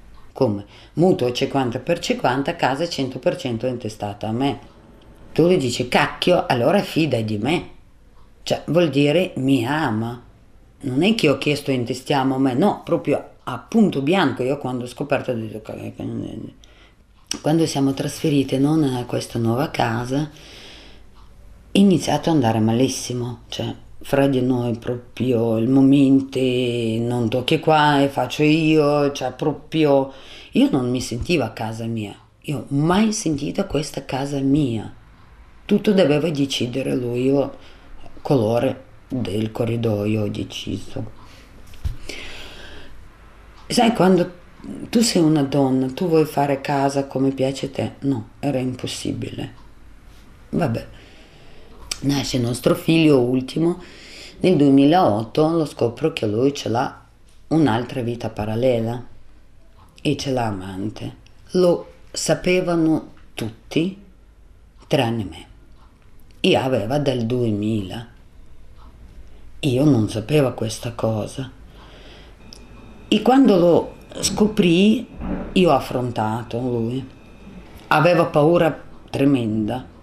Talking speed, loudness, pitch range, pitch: 120 wpm, -20 LUFS, 115-150 Hz, 130 Hz